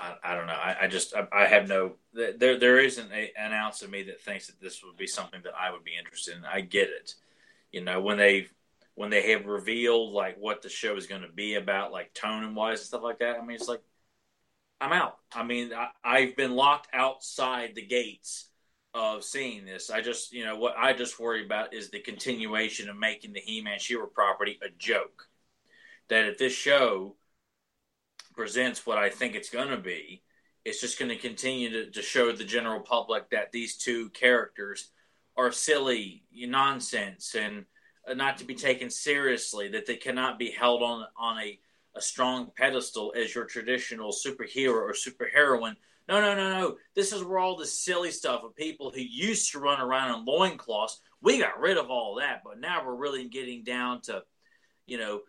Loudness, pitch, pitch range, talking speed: -28 LUFS, 120 Hz, 110-135 Hz, 200 wpm